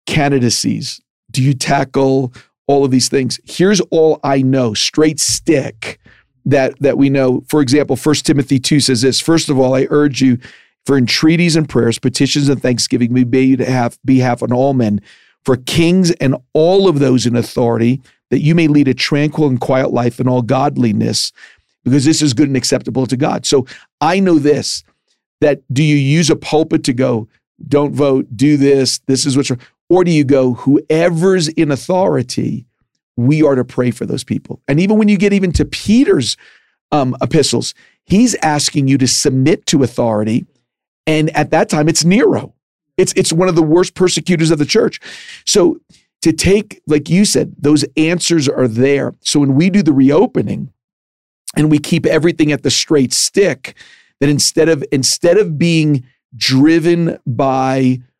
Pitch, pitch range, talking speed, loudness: 145 Hz, 130-160 Hz, 180 wpm, -13 LUFS